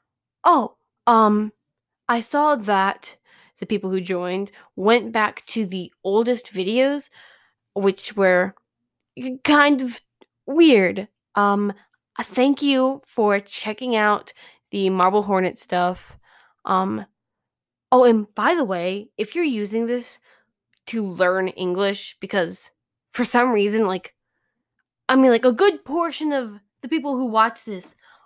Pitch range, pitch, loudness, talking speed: 195-255 Hz, 215 Hz, -20 LUFS, 125 wpm